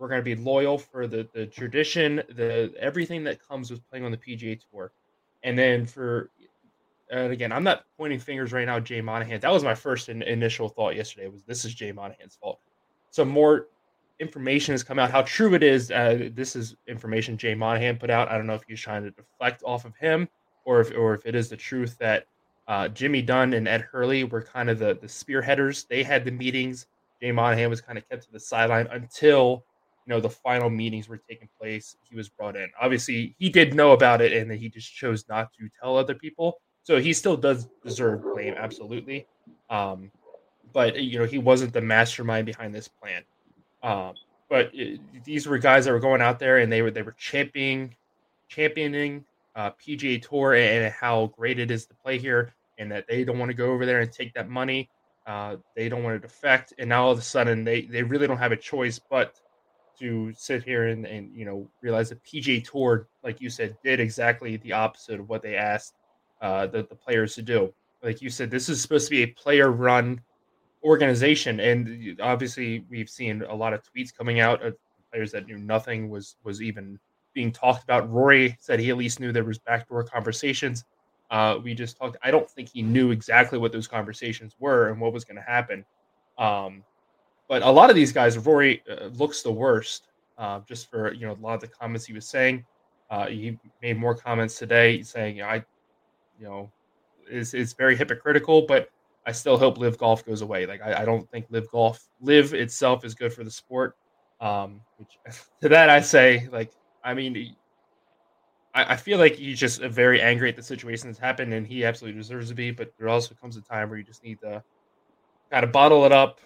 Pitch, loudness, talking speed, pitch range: 120 Hz, -23 LUFS, 215 wpm, 115-130 Hz